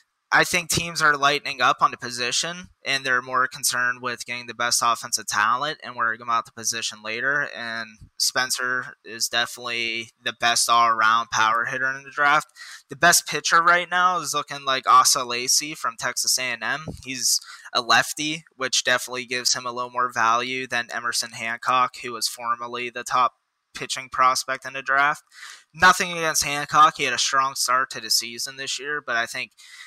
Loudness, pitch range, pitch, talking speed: -22 LUFS, 120-145 Hz, 125 Hz, 185 wpm